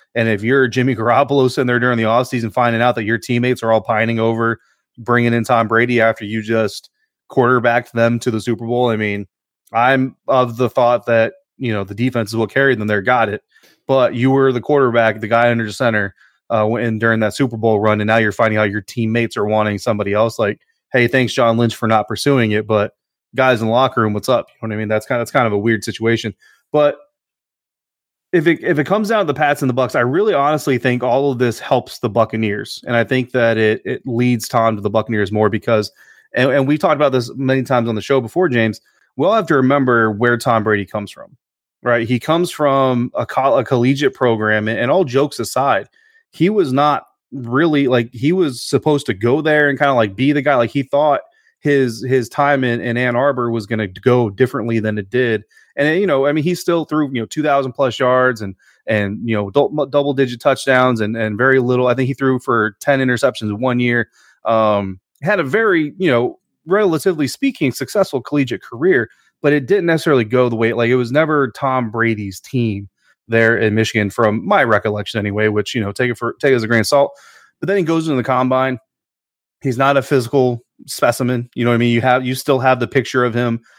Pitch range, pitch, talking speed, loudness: 115-135 Hz, 120 Hz, 230 wpm, -16 LUFS